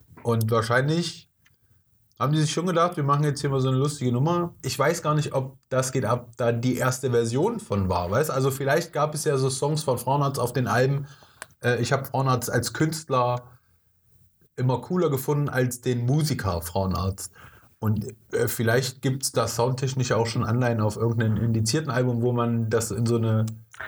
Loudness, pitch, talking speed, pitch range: -25 LUFS, 125 Hz, 185 wpm, 115-140 Hz